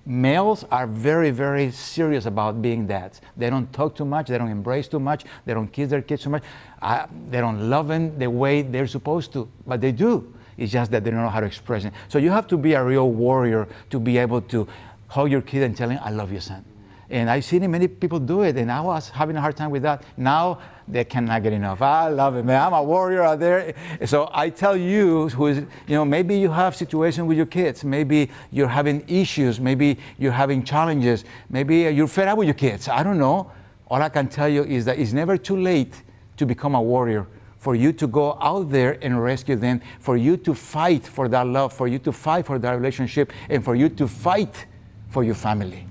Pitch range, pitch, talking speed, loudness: 120-150 Hz, 135 Hz, 235 wpm, -22 LUFS